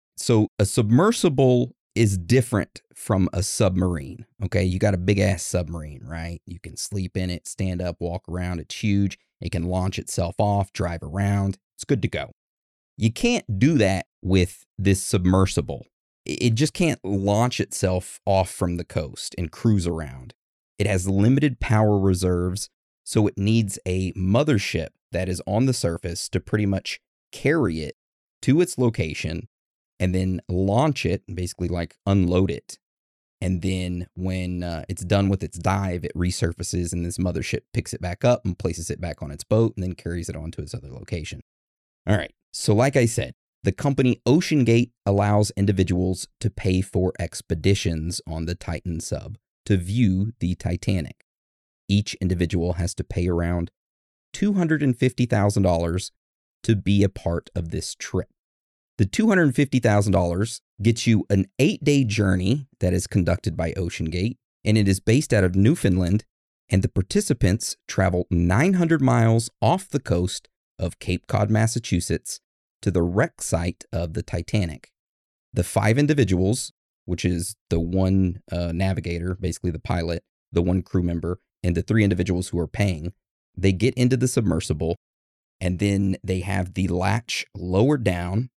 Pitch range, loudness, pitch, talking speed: 90-110 Hz, -23 LUFS, 95 Hz, 160 wpm